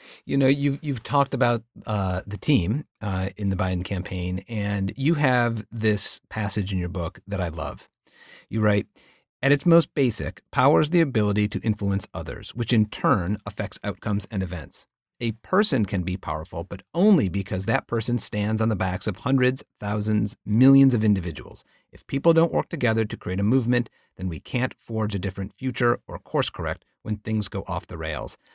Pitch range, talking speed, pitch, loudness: 95-120 Hz, 190 wpm, 105 Hz, -24 LUFS